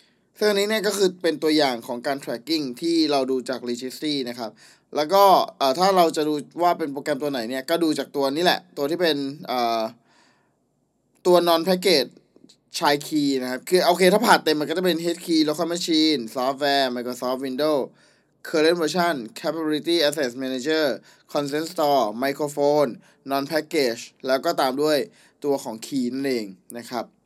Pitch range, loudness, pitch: 130-165 Hz, -22 LUFS, 150 Hz